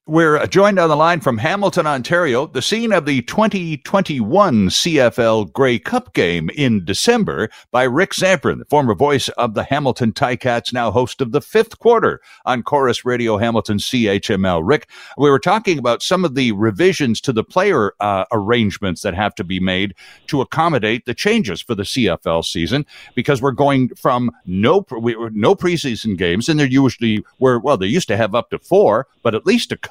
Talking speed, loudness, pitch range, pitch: 190 wpm, -16 LUFS, 115-170 Hz, 130 Hz